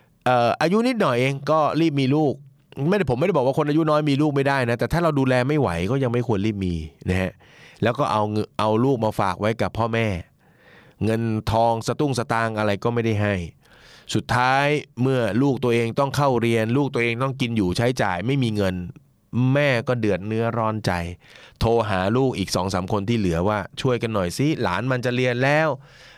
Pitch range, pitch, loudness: 110-140 Hz, 120 Hz, -22 LUFS